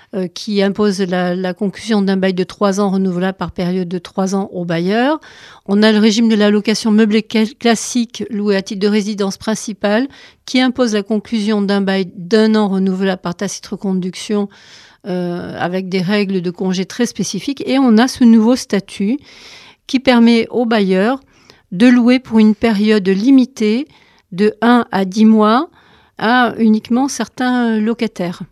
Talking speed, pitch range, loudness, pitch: 165 wpm, 195-230 Hz, -15 LUFS, 210 Hz